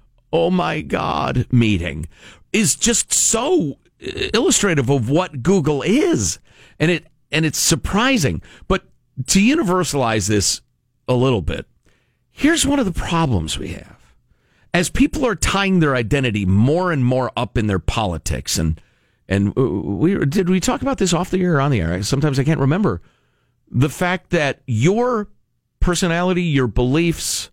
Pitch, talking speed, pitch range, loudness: 140 Hz, 155 wpm, 115-180 Hz, -18 LUFS